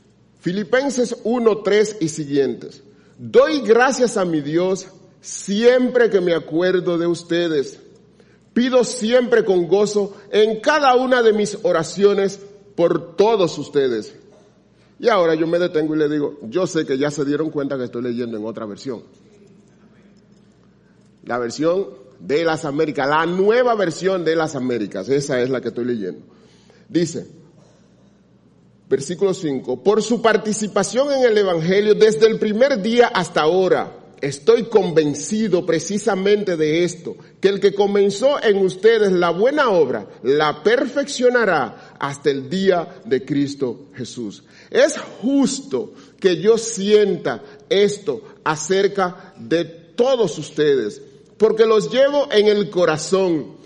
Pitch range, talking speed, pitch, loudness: 160-225 Hz, 135 wpm, 195 Hz, -18 LUFS